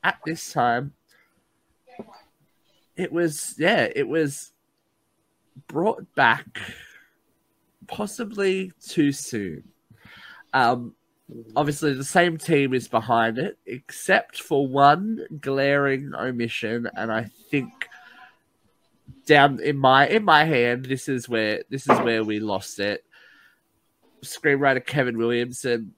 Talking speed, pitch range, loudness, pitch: 110 wpm, 120-150 Hz, -22 LUFS, 135 Hz